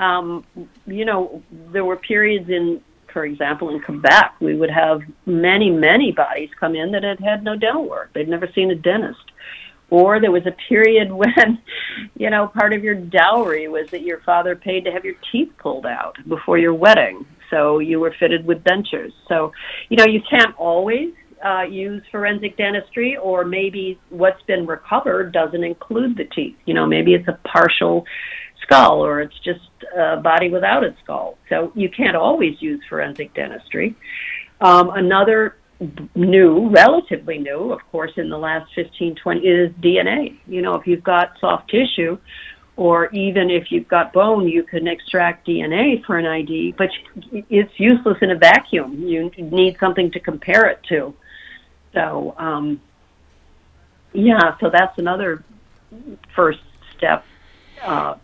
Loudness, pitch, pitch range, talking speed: -17 LUFS, 180 Hz, 165-210 Hz, 165 wpm